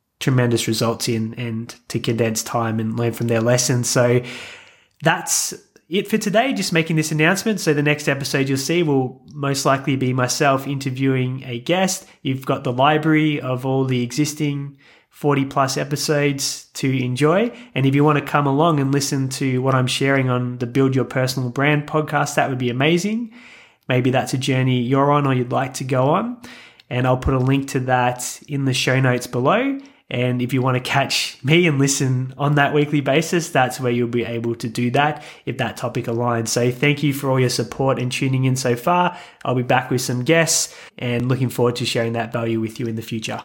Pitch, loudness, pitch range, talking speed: 135 Hz, -19 LUFS, 125-150 Hz, 210 wpm